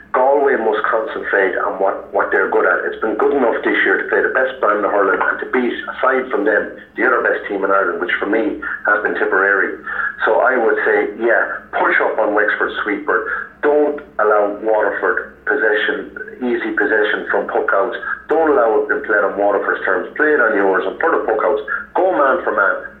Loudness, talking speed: -16 LUFS, 200 wpm